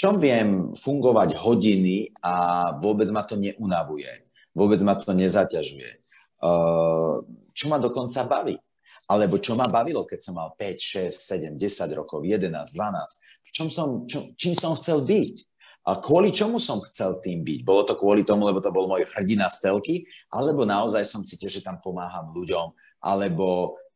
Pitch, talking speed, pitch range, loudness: 100 Hz, 165 wpm, 90-125 Hz, -24 LUFS